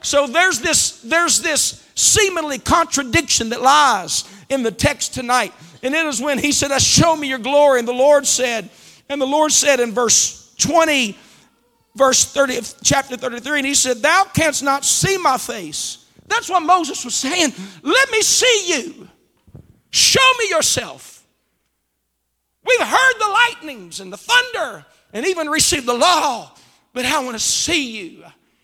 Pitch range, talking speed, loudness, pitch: 245-335 Hz, 165 wpm, -15 LUFS, 280 Hz